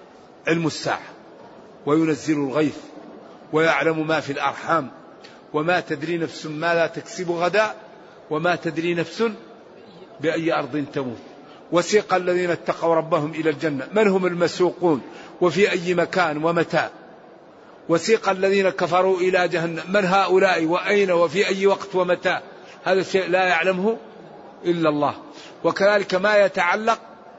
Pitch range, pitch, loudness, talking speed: 160-185 Hz, 175 Hz, -21 LUFS, 120 wpm